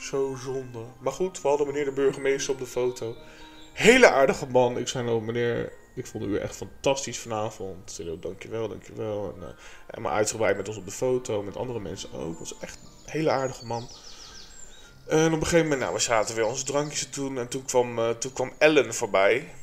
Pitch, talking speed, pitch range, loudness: 130 Hz, 215 wpm, 120-145 Hz, -26 LUFS